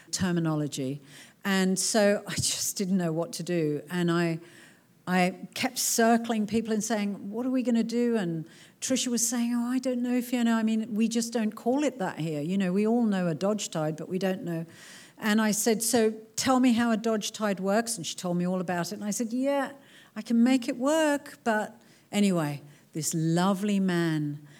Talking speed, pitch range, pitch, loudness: 210 wpm, 170-235 Hz, 205 Hz, -27 LUFS